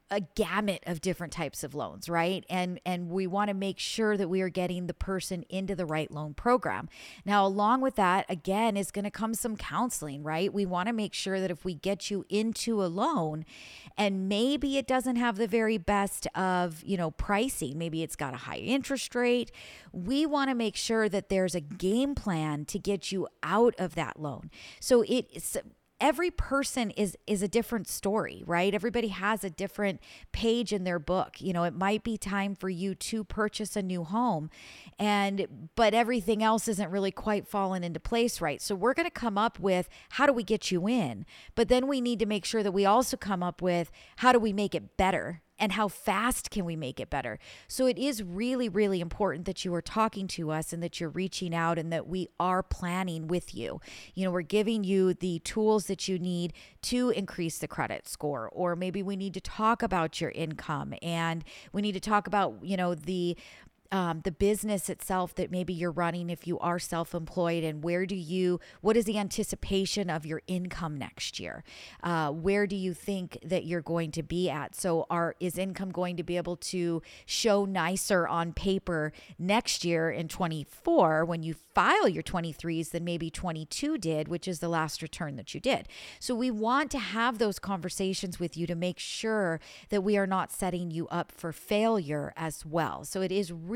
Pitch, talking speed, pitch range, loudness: 190 Hz, 205 wpm, 170-215 Hz, -30 LUFS